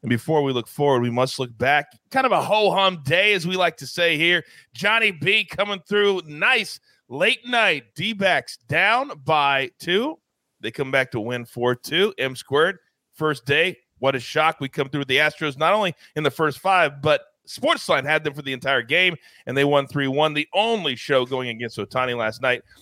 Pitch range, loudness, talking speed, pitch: 130-185 Hz, -21 LUFS, 210 wpm, 150 Hz